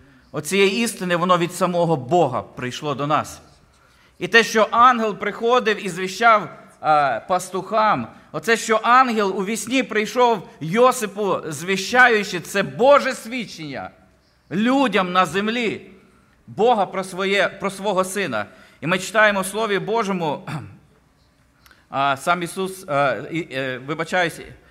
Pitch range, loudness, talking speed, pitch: 170-220 Hz, -19 LUFS, 125 wpm, 195 Hz